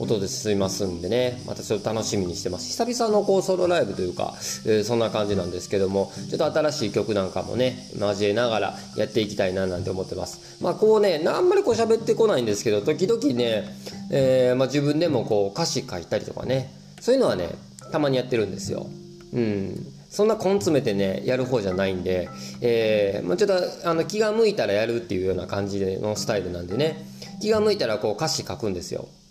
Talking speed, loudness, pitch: 430 characters per minute, -24 LUFS, 115 Hz